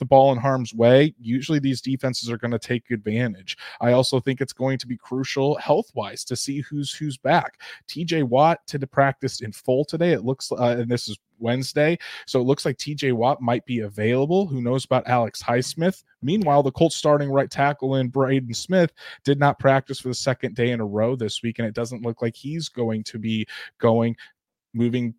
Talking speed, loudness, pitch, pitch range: 210 wpm, -23 LUFS, 130 Hz, 120-140 Hz